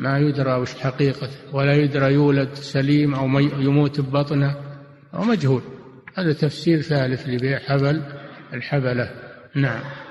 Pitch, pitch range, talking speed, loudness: 140 Hz, 135-145 Hz, 120 wpm, -21 LUFS